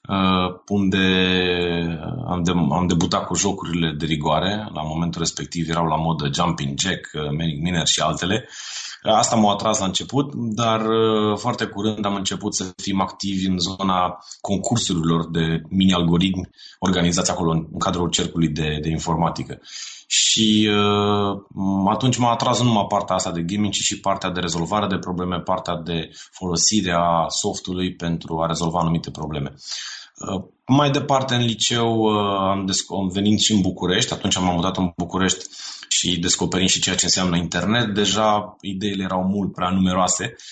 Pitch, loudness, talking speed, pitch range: 95 Hz, -21 LUFS, 155 wpm, 85-105 Hz